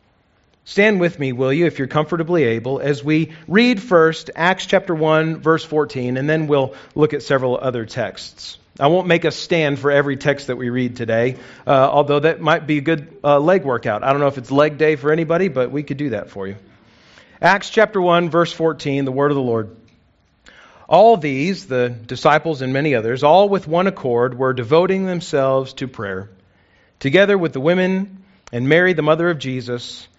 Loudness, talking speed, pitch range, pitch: -17 LUFS, 200 wpm, 125-165 Hz, 145 Hz